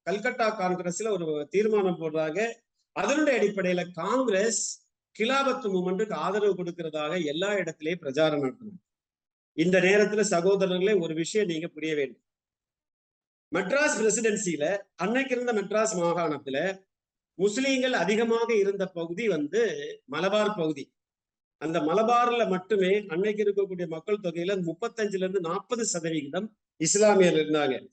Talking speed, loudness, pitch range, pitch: 105 wpm, -27 LUFS, 165-215 Hz, 195 Hz